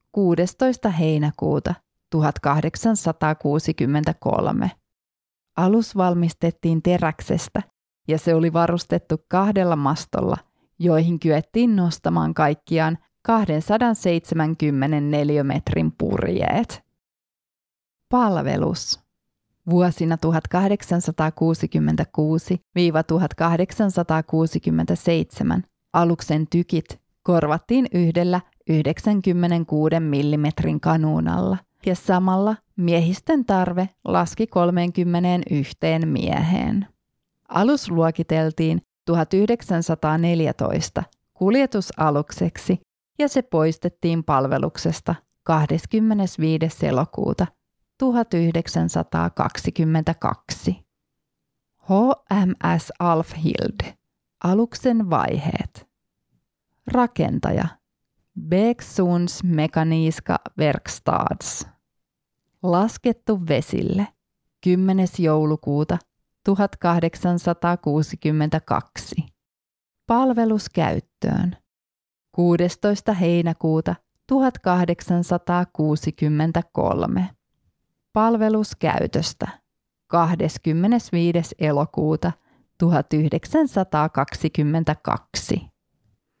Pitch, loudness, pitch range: 170 Hz, -21 LUFS, 155-185 Hz